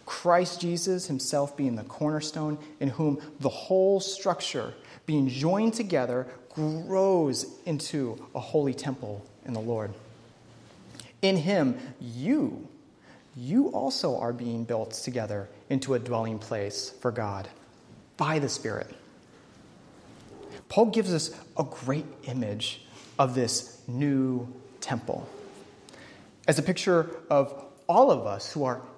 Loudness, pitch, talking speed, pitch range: -28 LUFS, 140 Hz, 120 wpm, 125-165 Hz